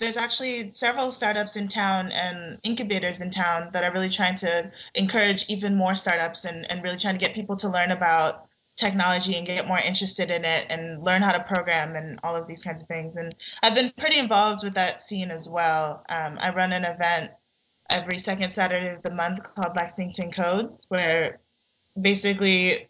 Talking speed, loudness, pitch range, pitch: 195 wpm, -24 LUFS, 170-200 Hz, 180 Hz